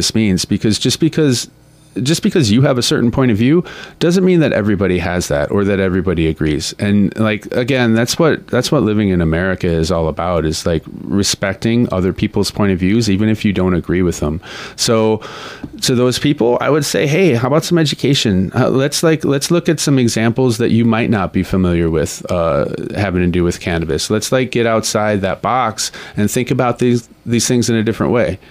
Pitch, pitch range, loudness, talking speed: 110 Hz, 95-125 Hz, -15 LUFS, 210 wpm